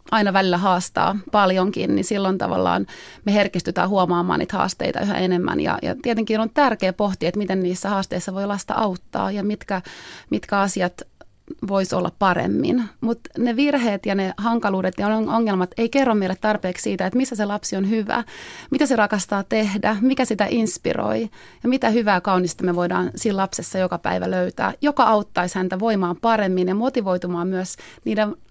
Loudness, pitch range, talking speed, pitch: -21 LUFS, 185-225 Hz, 170 wpm, 200 Hz